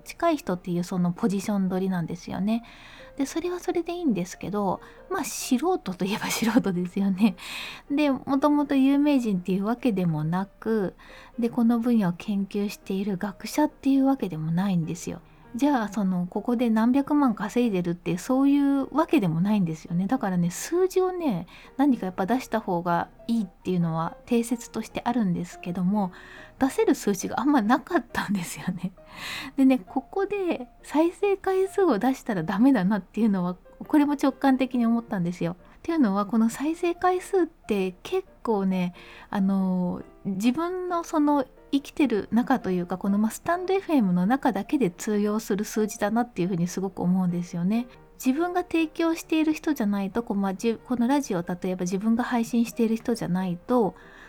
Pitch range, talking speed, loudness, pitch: 190-280 Hz, 375 characters per minute, -26 LUFS, 230 Hz